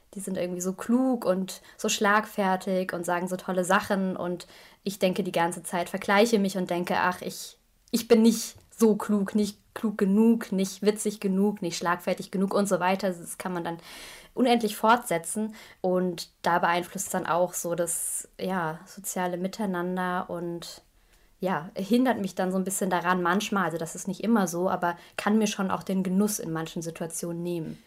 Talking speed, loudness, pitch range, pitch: 185 wpm, -27 LUFS, 175-205 Hz, 190 Hz